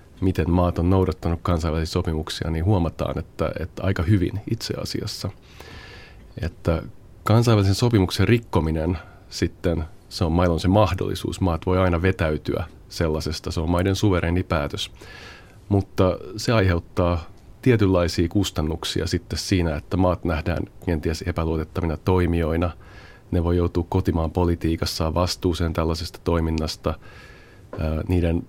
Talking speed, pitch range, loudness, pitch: 120 wpm, 85-100 Hz, -23 LUFS, 90 Hz